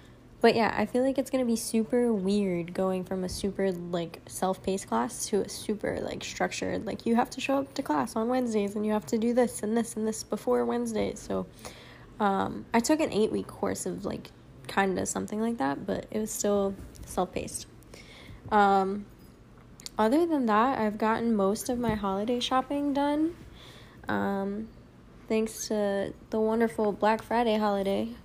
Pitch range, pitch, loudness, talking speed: 200-240 Hz, 220 Hz, -29 LUFS, 175 wpm